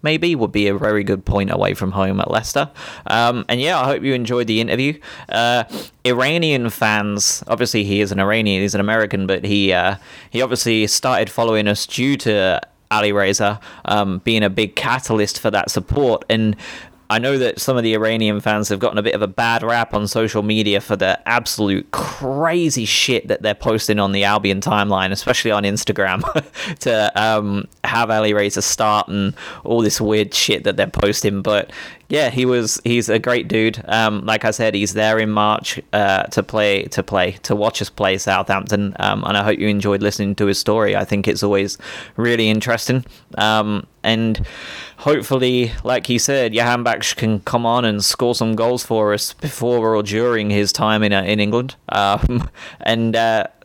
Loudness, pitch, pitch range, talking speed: -17 LUFS, 110 Hz, 105-115 Hz, 190 wpm